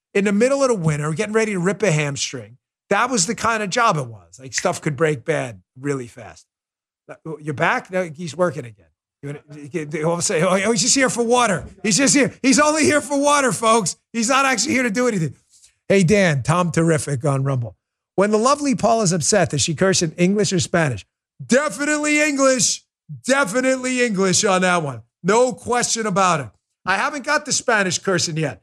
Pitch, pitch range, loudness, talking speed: 185 Hz, 150-240 Hz, -18 LUFS, 195 wpm